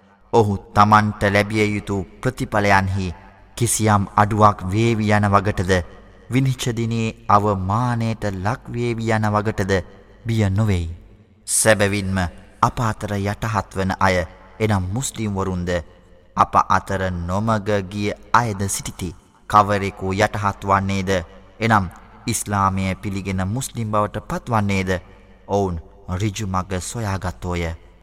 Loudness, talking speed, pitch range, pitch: -20 LUFS, 80 wpm, 95-110 Hz, 100 Hz